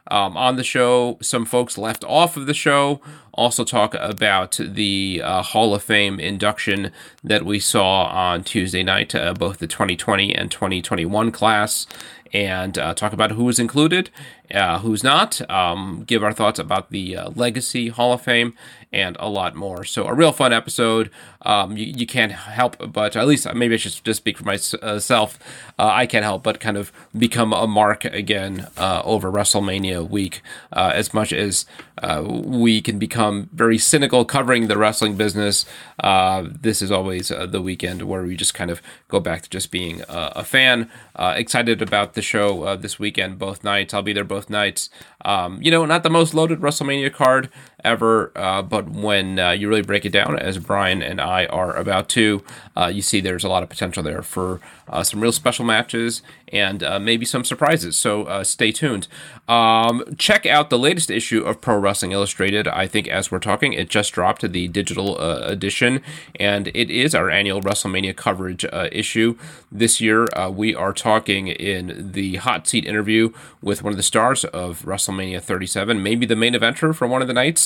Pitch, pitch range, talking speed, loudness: 105 Hz, 95-120 Hz, 195 wpm, -19 LUFS